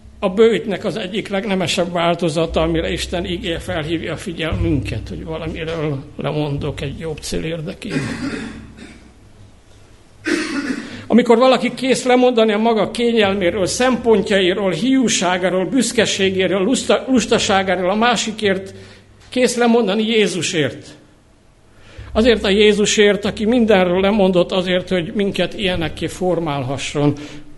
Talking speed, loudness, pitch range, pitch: 100 wpm, -17 LUFS, 155-215 Hz, 185 Hz